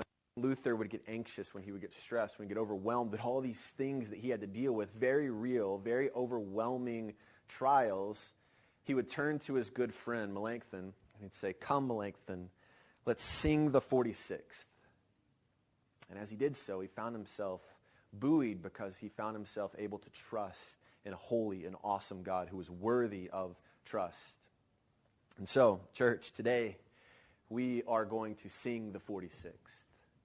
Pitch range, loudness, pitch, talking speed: 100-125 Hz, -38 LUFS, 110 Hz, 165 wpm